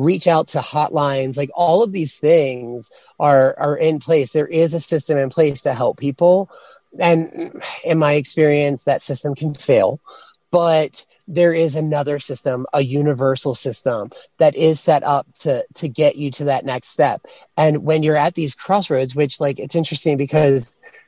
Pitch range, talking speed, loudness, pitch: 140-160 Hz, 175 wpm, -17 LUFS, 150 Hz